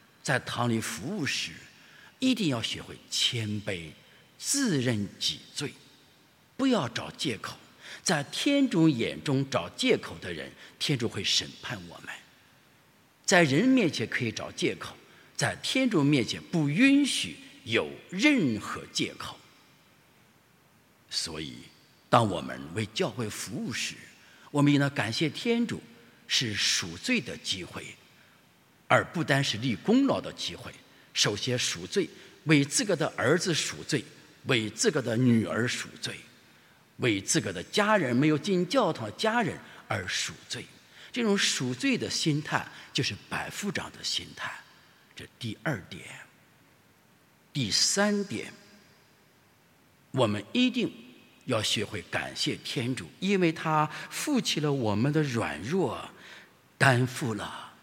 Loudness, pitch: -28 LUFS, 150 Hz